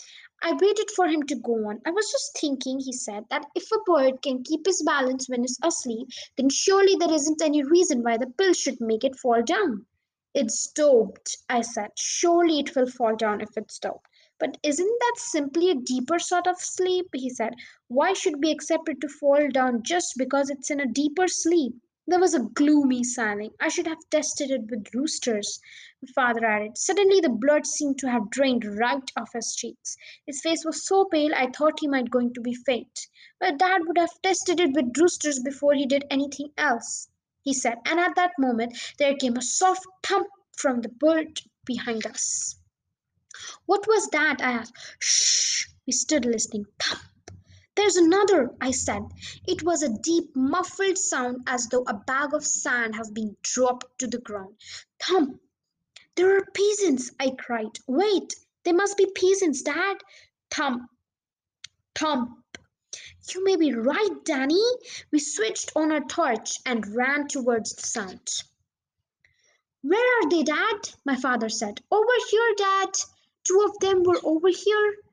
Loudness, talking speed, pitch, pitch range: -24 LUFS, 175 wpm, 295 Hz, 250-360 Hz